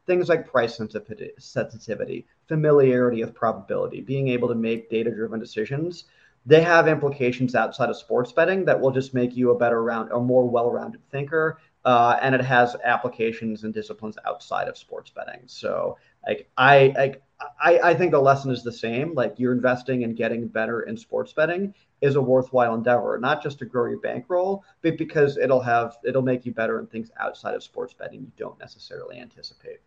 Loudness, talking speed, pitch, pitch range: -23 LUFS, 185 wpm, 130 Hz, 120-155 Hz